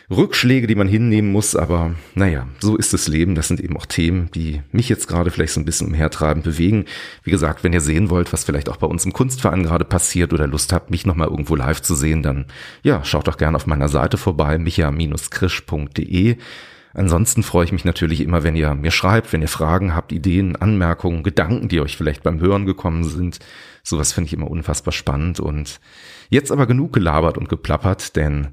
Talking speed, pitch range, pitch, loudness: 205 wpm, 80-95 Hz, 85 Hz, -18 LUFS